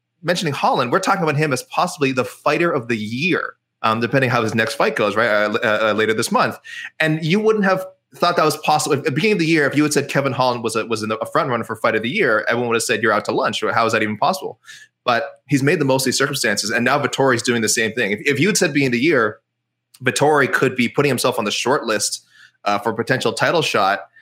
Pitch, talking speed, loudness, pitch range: 135 Hz, 275 wpm, -18 LUFS, 120-155 Hz